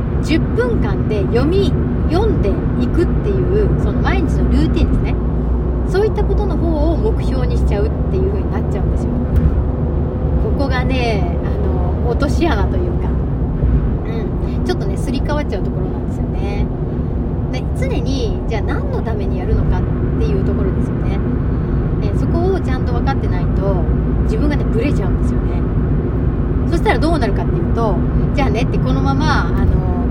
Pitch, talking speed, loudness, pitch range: 75 Hz, 355 characters per minute, -17 LUFS, 75-80 Hz